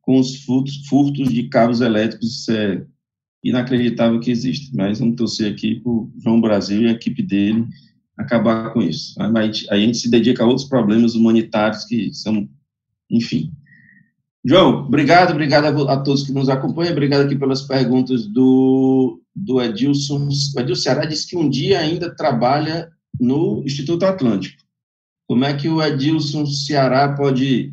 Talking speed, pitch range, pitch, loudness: 160 wpm, 115-140 Hz, 130 Hz, -17 LUFS